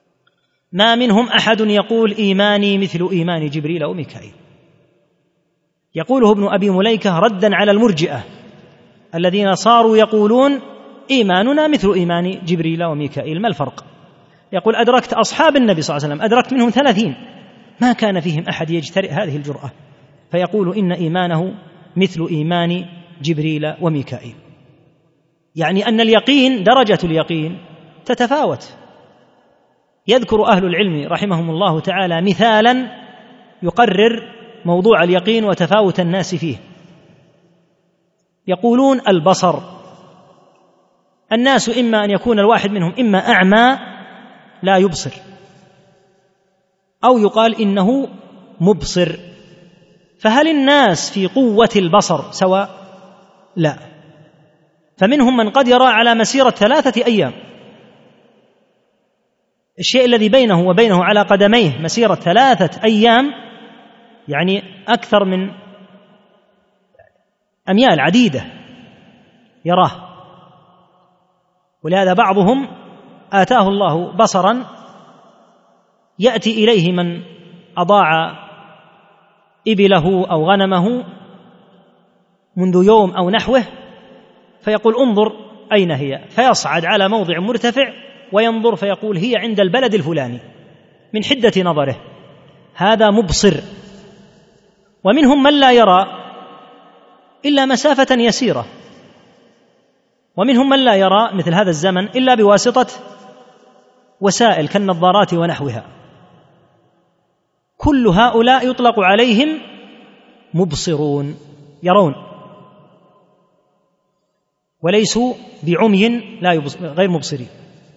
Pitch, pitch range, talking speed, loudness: 195 Hz, 175-230 Hz, 95 wpm, -14 LUFS